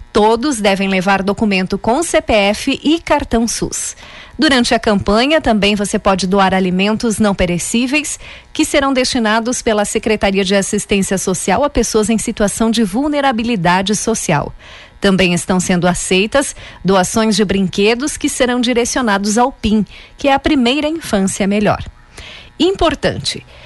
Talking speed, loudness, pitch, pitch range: 135 wpm, -14 LUFS, 220 Hz, 200-250 Hz